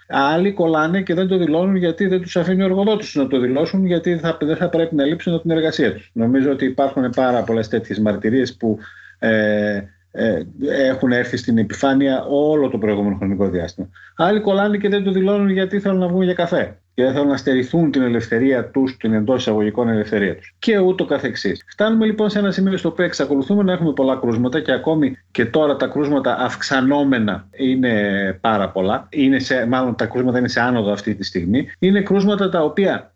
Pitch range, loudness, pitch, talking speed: 120-180 Hz, -18 LUFS, 135 Hz, 195 wpm